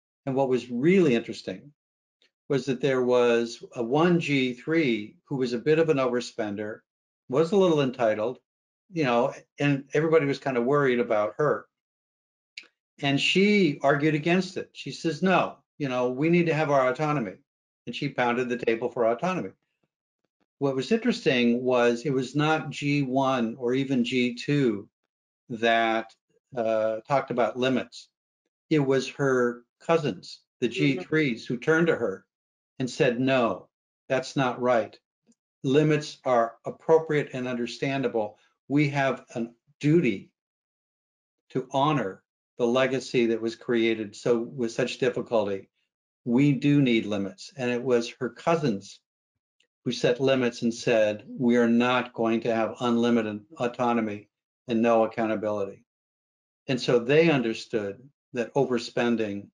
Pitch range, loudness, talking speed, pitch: 115-145 Hz, -26 LUFS, 140 wpm, 125 Hz